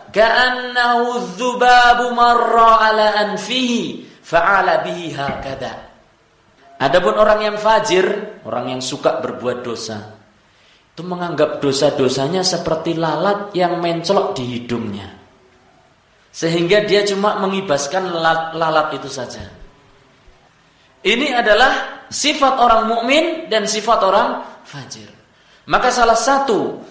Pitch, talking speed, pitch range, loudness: 195 Hz, 85 wpm, 150-230 Hz, -16 LUFS